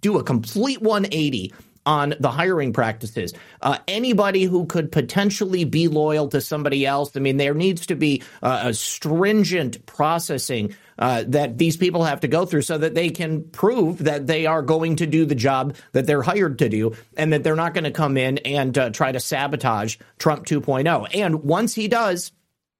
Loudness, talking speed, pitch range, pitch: -21 LUFS, 190 wpm, 140-170 Hz, 155 Hz